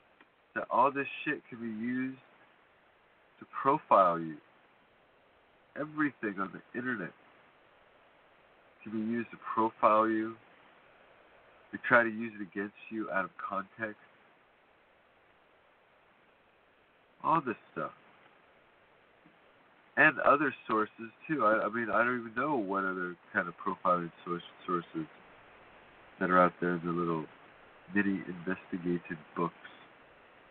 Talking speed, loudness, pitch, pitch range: 120 wpm, -32 LUFS, 100 Hz, 90-115 Hz